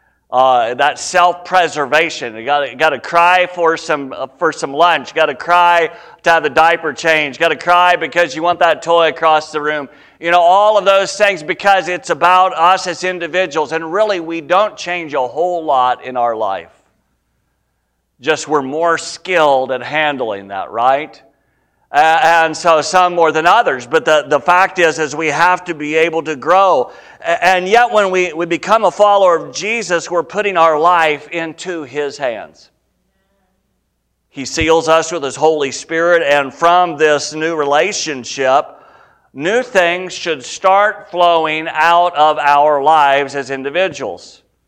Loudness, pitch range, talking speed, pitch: -13 LUFS, 150-180 Hz, 165 wpm, 165 Hz